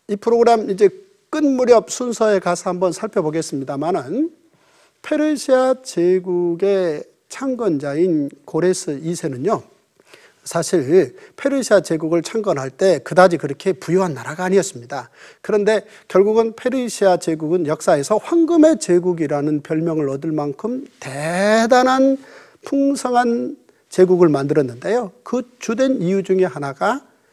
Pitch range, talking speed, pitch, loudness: 170-260 Hz, 290 characters per minute, 200 Hz, -18 LUFS